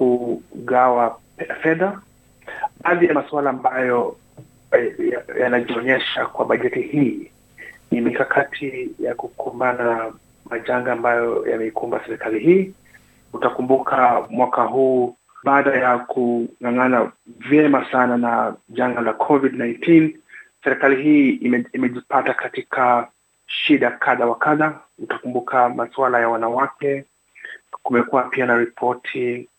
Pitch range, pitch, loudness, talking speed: 120-155 Hz, 125 Hz, -19 LUFS, 105 wpm